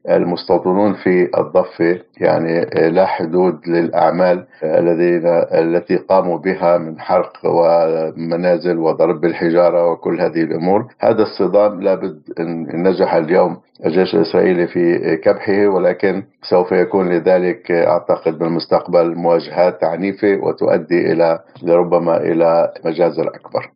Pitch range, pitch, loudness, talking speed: 85-90 Hz, 85 Hz, -15 LUFS, 110 wpm